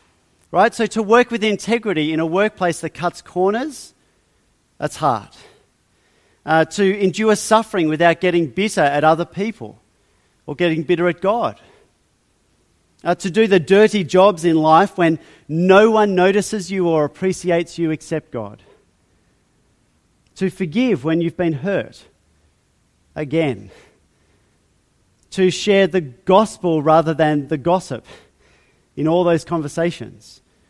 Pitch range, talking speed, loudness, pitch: 160-195 Hz, 130 wpm, -17 LUFS, 175 Hz